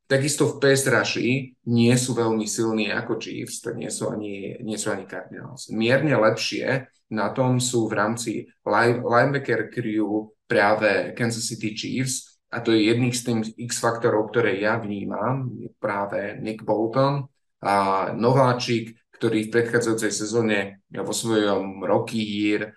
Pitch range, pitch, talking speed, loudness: 110-120 Hz, 115 Hz, 150 wpm, -23 LUFS